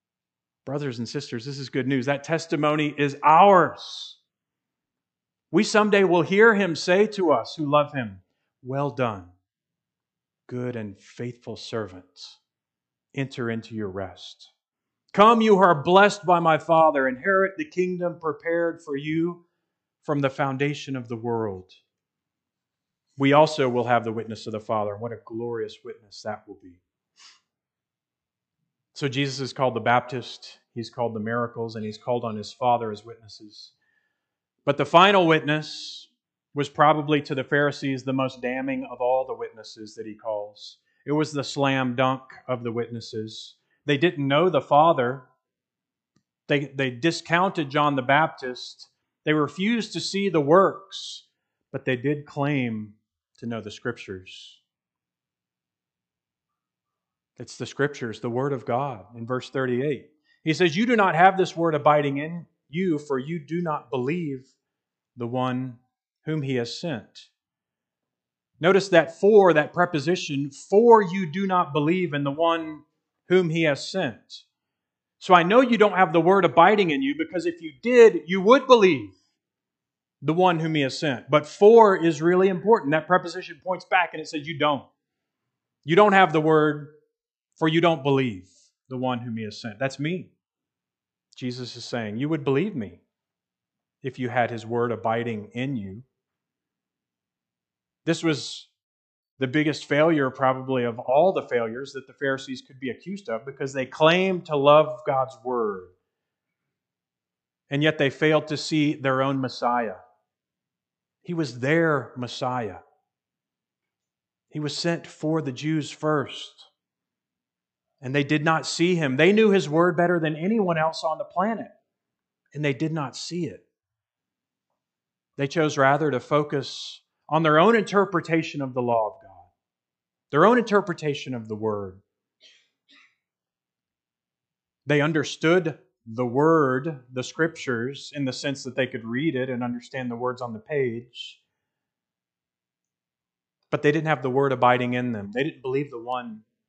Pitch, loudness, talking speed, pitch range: 140 Hz, -23 LUFS, 155 wpm, 120-165 Hz